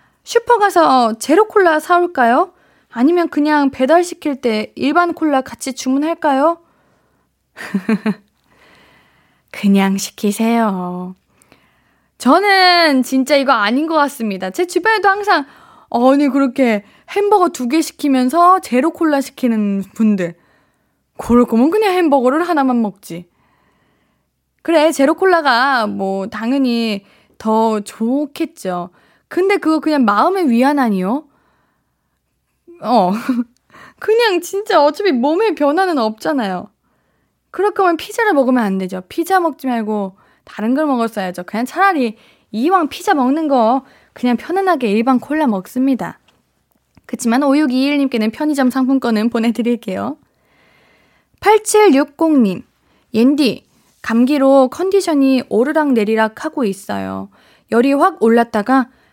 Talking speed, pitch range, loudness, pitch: 250 characters per minute, 225-325 Hz, -15 LUFS, 265 Hz